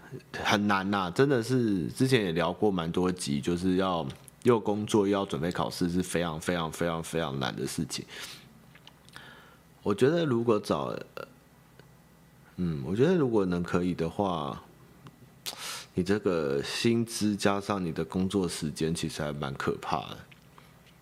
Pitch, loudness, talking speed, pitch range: 95 Hz, -29 LUFS, 220 characters per minute, 85-105 Hz